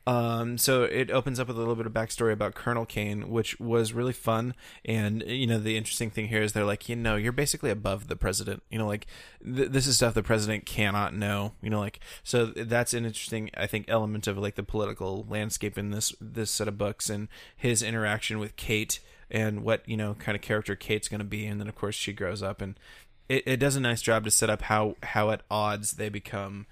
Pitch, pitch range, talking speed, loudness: 110 Hz, 105-115 Hz, 240 wpm, -29 LUFS